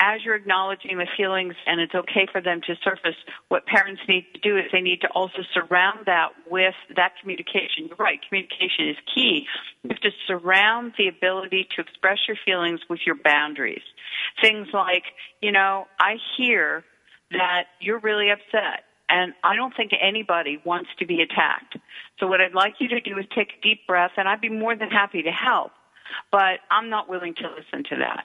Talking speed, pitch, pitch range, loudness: 195 wpm, 190 Hz, 180-215 Hz, -22 LUFS